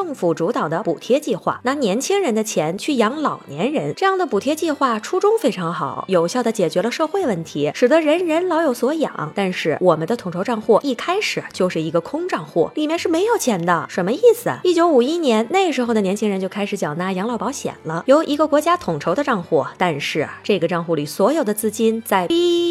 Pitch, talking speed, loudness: 235 Hz, 335 characters per minute, -19 LUFS